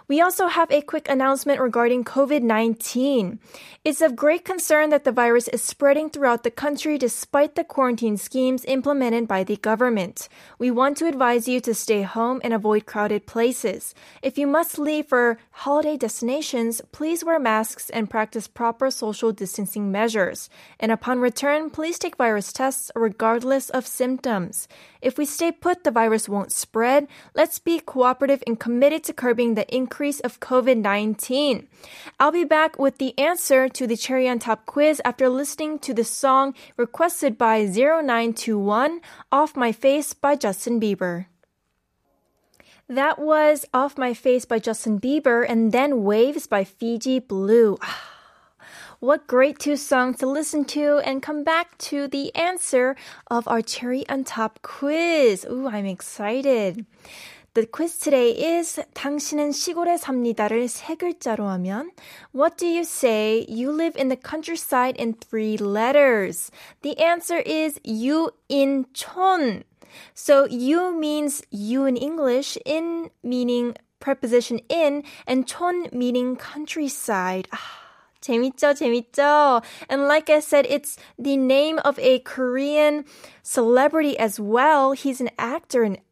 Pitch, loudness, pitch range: 265 Hz, -22 LUFS, 235-295 Hz